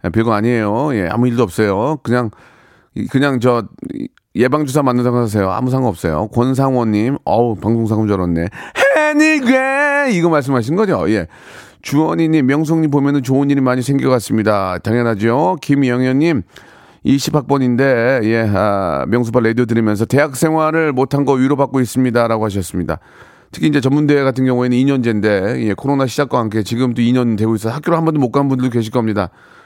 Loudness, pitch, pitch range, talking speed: -15 LUFS, 125 Hz, 115-145 Hz, 370 characters per minute